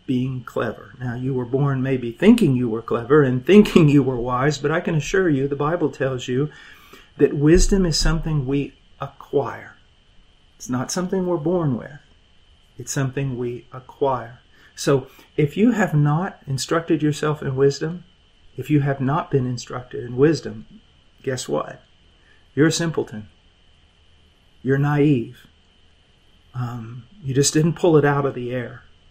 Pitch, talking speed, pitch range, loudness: 135 Hz, 155 wpm, 120-150 Hz, -21 LUFS